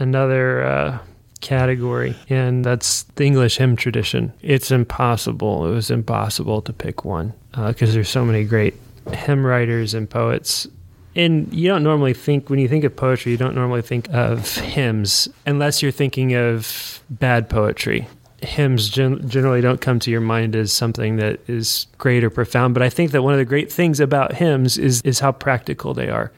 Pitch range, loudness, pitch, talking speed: 115-135 Hz, -19 LUFS, 125 Hz, 185 wpm